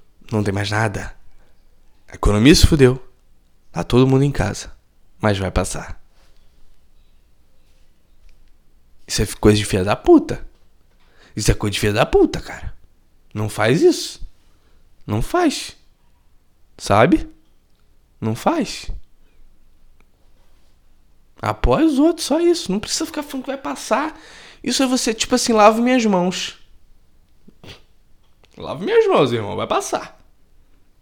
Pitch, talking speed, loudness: 110 Hz, 125 wpm, -18 LUFS